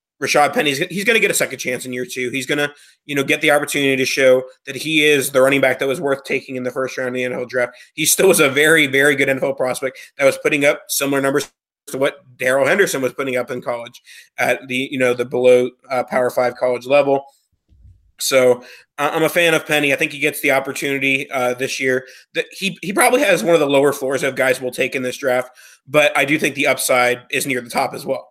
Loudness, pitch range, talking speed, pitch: -17 LUFS, 125-145 Hz, 250 wpm, 135 Hz